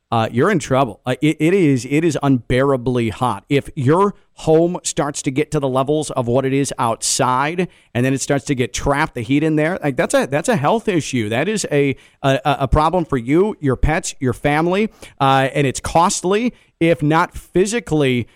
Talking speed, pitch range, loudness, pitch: 205 wpm, 130-160 Hz, -18 LUFS, 145 Hz